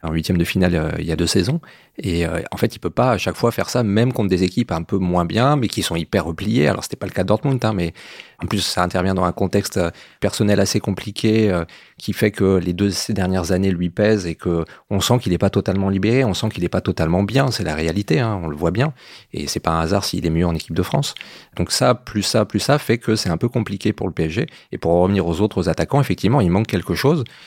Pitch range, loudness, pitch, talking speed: 85-110 Hz, -19 LUFS, 95 Hz, 280 wpm